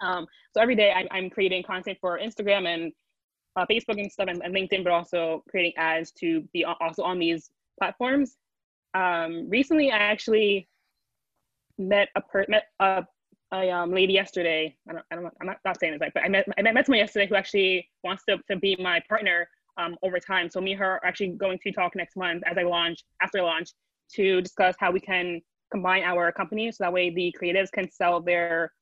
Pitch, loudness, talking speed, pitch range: 185 Hz, -25 LUFS, 210 wpm, 175-200 Hz